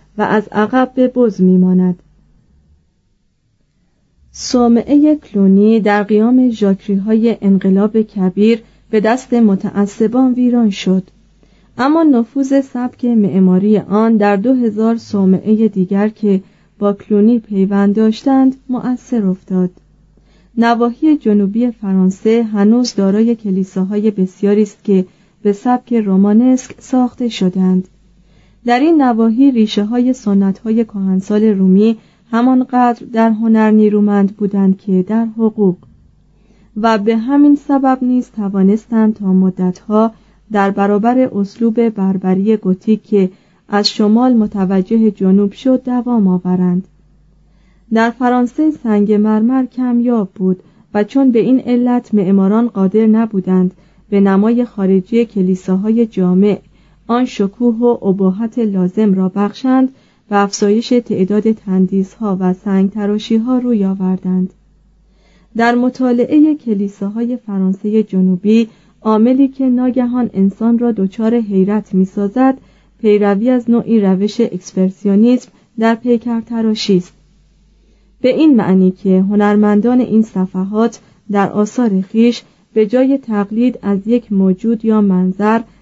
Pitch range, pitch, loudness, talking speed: 195-235 Hz, 210 Hz, -13 LUFS, 115 wpm